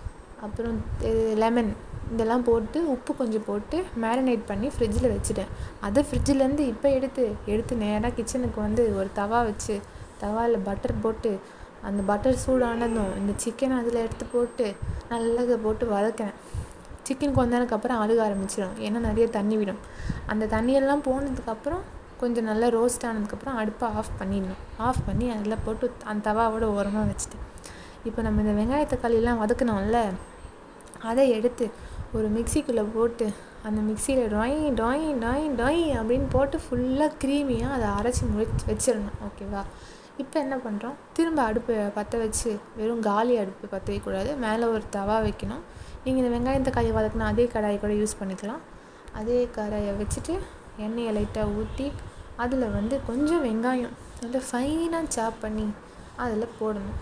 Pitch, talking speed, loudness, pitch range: 230 Hz, 135 wpm, -27 LUFS, 215-255 Hz